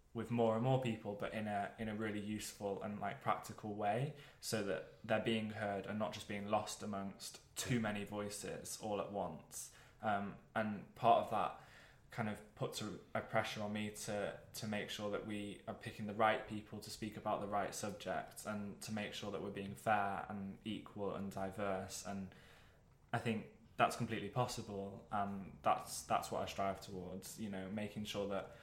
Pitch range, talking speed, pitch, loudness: 100-110 Hz, 195 wpm, 105 Hz, -42 LUFS